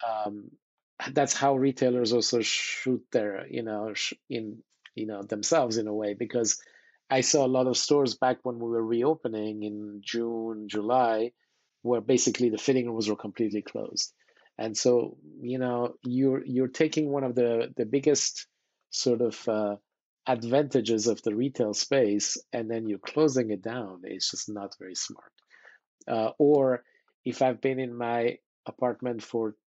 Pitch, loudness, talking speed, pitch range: 120 Hz, -28 LUFS, 160 wpm, 110-130 Hz